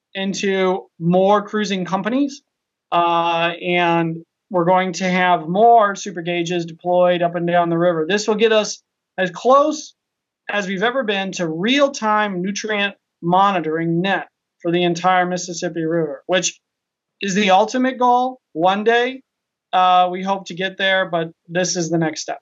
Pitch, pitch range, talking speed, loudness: 185 Hz, 175-210 Hz, 160 wpm, -18 LUFS